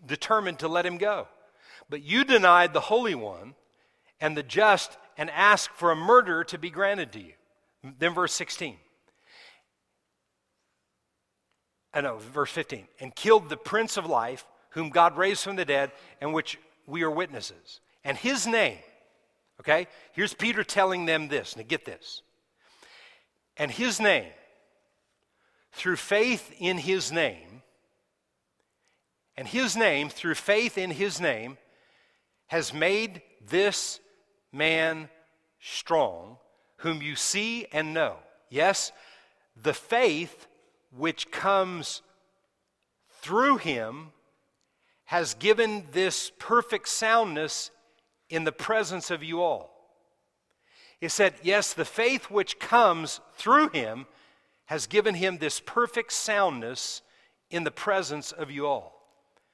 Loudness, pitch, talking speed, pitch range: -26 LUFS, 180 Hz, 125 wpm, 155-210 Hz